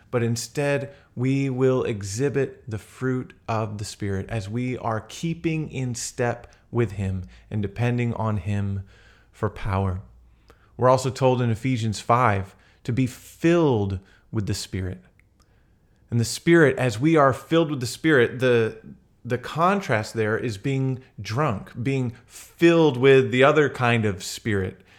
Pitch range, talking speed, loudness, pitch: 105-130 Hz, 145 wpm, -23 LUFS, 120 Hz